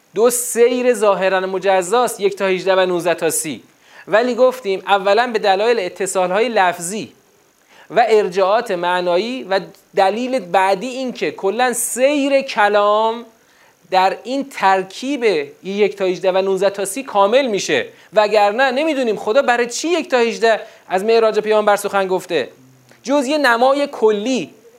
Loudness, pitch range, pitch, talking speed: -16 LUFS, 190-250 Hz, 215 Hz, 140 wpm